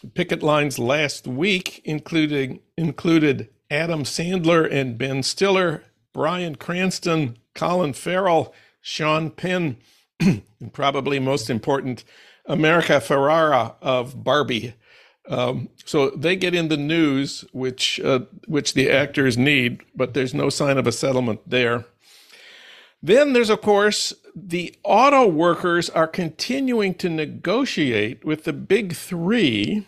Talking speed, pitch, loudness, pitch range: 125 wpm, 155 Hz, -21 LUFS, 135-175 Hz